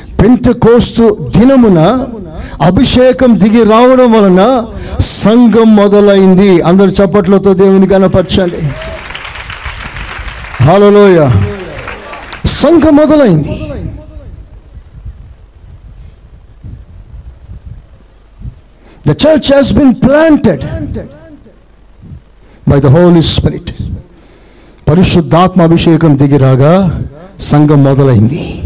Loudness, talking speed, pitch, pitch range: -6 LUFS, 45 wpm, 195 Hz, 165-235 Hz